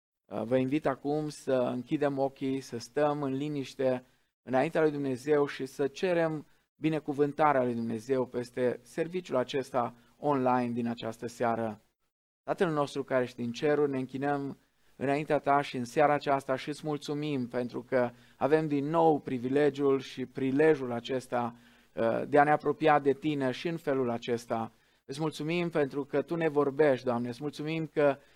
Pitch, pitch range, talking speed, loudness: 140 Hz, 125-150 Hz, 155 wpm, -30 LUFS